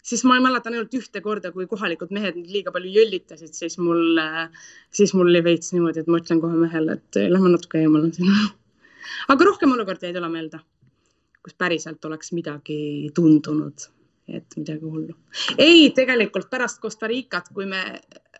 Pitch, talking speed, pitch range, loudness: 180 Hz, 165 wpm, 160-220 Hz, -20 LUFS